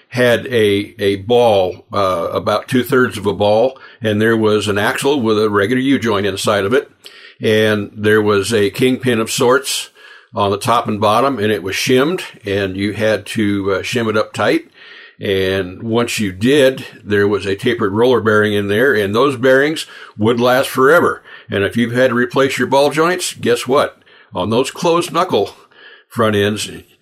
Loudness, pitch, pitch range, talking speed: -15 LUFS, 110 Hz, 105-130 Hz, 185 wpm